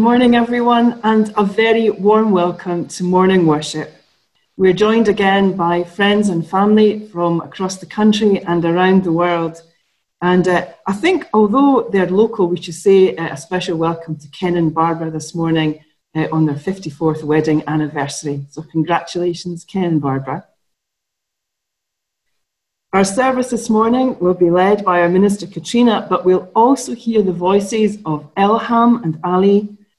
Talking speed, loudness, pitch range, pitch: 155 wpm, -15 LUFS, 165-210 Hz, 180 Hz